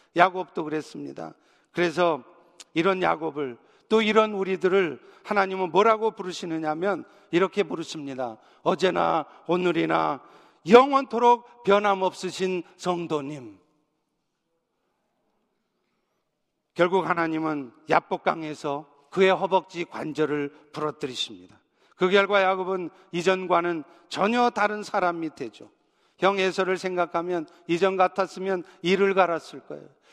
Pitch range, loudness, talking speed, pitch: 160-190 Hz, -25 LUFS, 260 characters per minute, 180 Hz